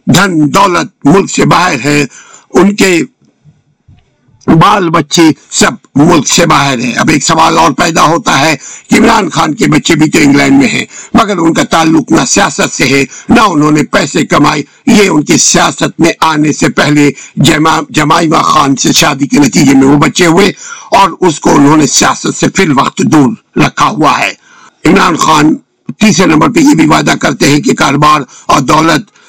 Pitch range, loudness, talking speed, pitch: 145-170 Hz, -7 LUFS, 170 wpm, 150 Hz